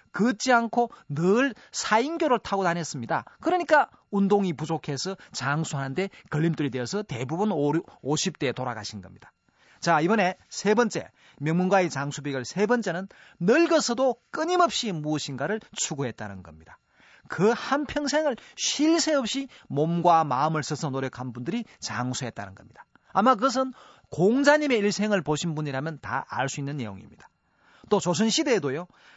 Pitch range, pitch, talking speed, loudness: 140-235 Hz, 175 Hz, 325 characters per minute, -26 LUFS